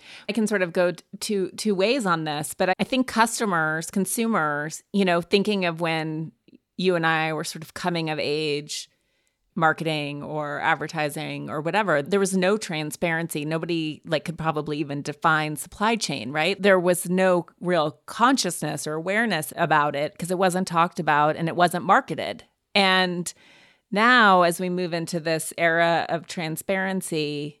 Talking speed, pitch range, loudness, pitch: 165 wpm, 155-190 Hz, -23 LUFS, 170 Hz